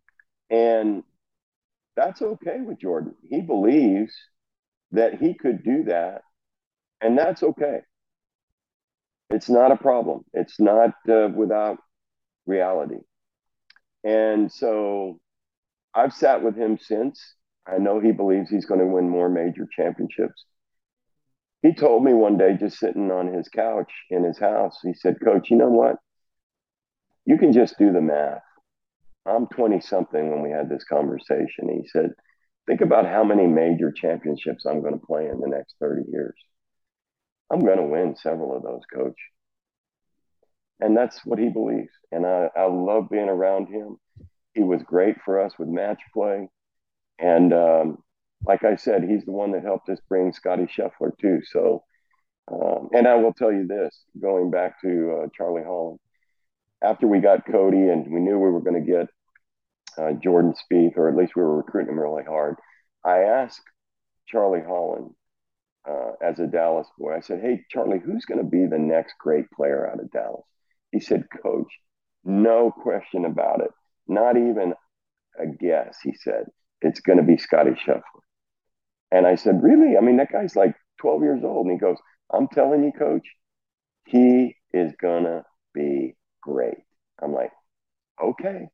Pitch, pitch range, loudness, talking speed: 95 Hz, 85-115 Hz, -22 LUFS, 165 wpm